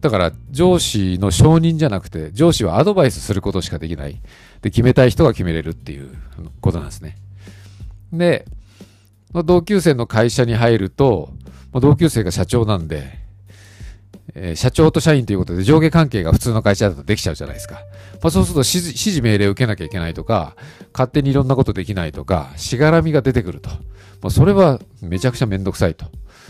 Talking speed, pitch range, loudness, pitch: 410 characters per minute, 95-135 Hz, -16 LUFS, 100 Hz